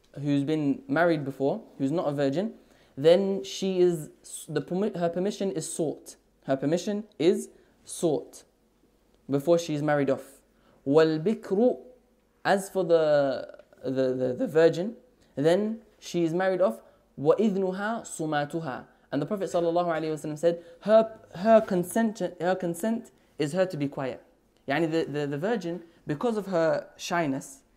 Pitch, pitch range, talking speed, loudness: 170 Hz, 145-195 Hz, 135 wpm, -27 LUFS